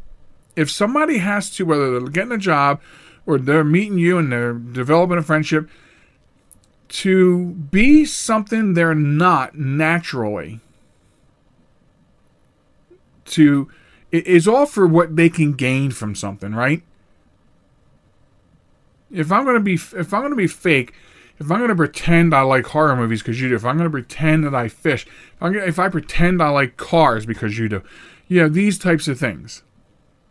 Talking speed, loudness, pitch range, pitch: 160 wpm, -17 LUFS, 130-180 Hz, 160 Hz